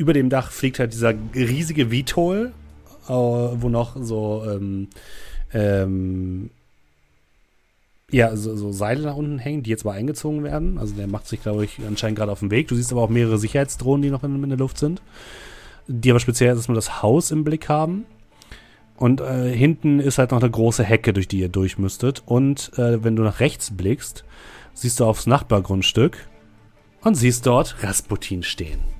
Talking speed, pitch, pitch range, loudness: 180 wpm, 120 Hz, 105-135 Hz, -21 LUFS